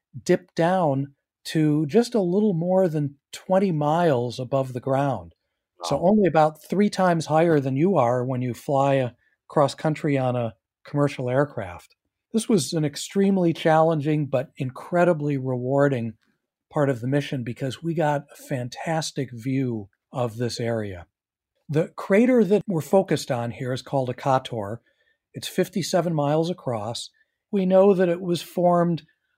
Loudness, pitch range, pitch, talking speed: -23 LUFS, 130-175 Hz, 145 Hz, 150 wpm